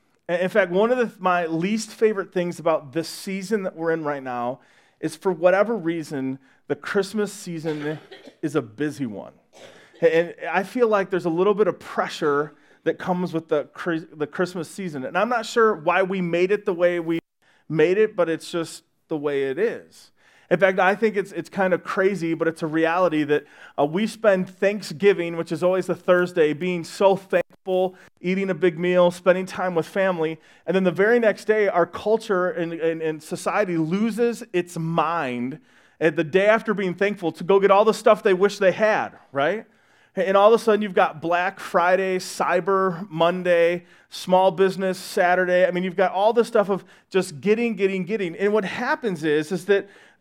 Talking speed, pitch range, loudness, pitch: 195 wpm, 165-200 Hz, -22 LUFS, 180 Hz